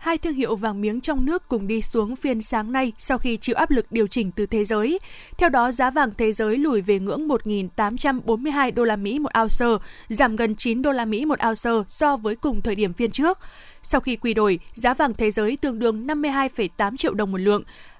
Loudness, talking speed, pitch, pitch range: -22 LUFS, 225 wpm, 235 Hz, 215-275 Hz